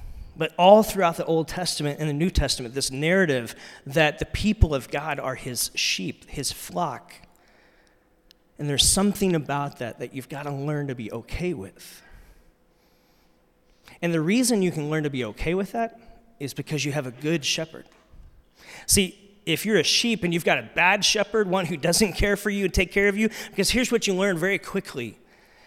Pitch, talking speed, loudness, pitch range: 165 Hz, 195 wpm, -23 LUFS, 140-200 Hz